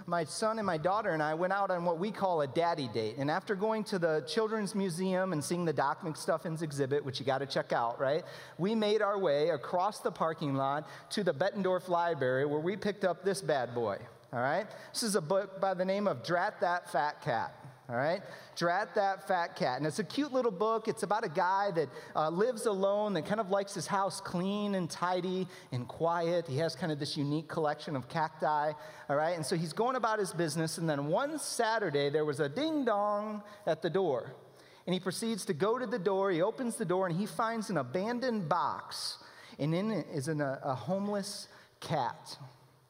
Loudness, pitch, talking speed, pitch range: -33 LUFS, 185 Hz, 220 wpm, 155-205 Hz